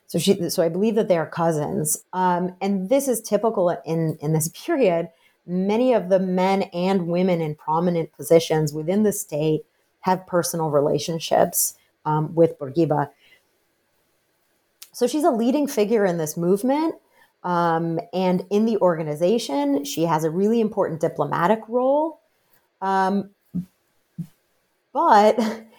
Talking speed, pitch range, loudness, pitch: 135 wpm, 165-210 Hz, -22 LUFS, 180 Hz